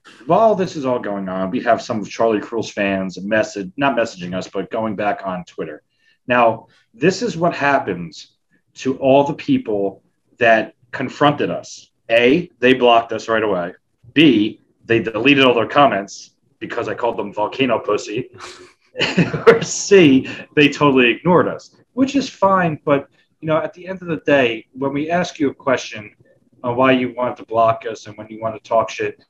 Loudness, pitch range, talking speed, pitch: -17 LUFS, 110-155 Hz, 185 wpm, 125 Hz